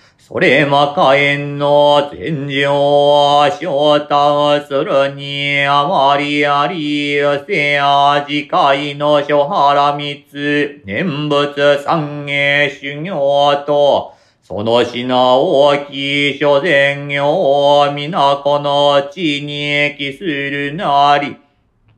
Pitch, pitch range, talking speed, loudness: 145 Hz, 140-145 Hz, 160 characters per minute, -13 LUFS